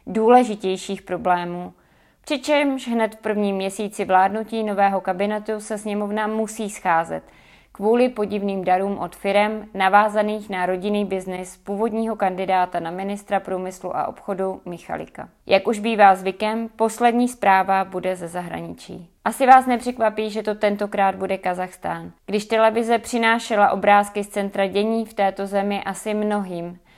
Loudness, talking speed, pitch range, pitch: -21 LUFS, 135 wpm, 190-220 Hz, 200 Hz